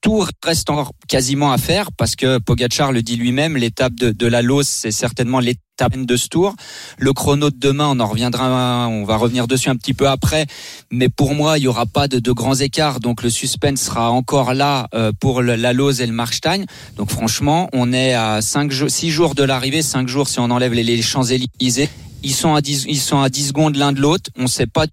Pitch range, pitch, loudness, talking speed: 120-145 Hz, 130 Hz, -17 LUFS, 235 wpm